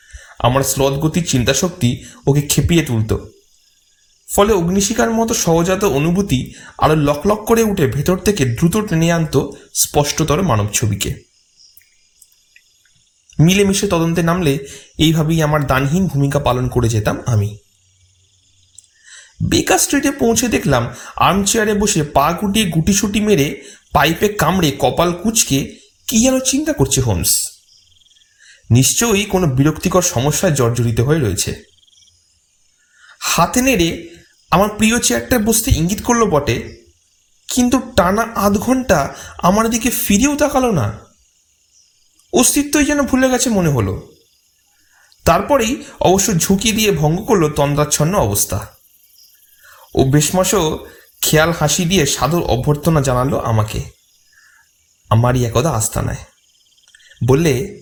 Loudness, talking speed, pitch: -15 LUFS, 115 wpm, 155 Hz